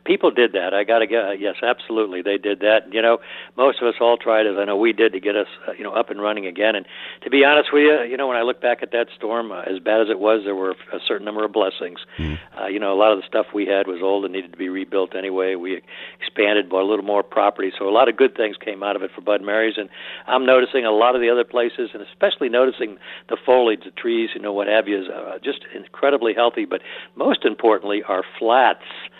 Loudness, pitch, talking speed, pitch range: -20 LUFS, 110 Hz, 275 wpm, 100-120 Hz